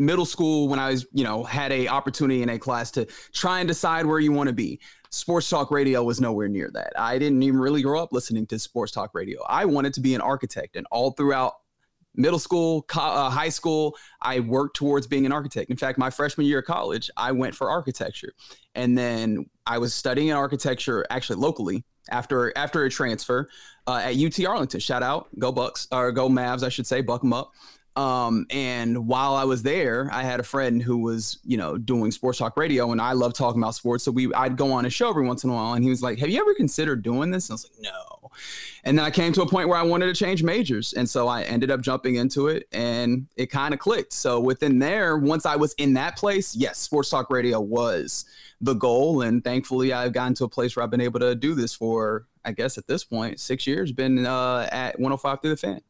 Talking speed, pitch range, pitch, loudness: 240 wpm, 120-145 Hz, 130 Hz, -24 LUFS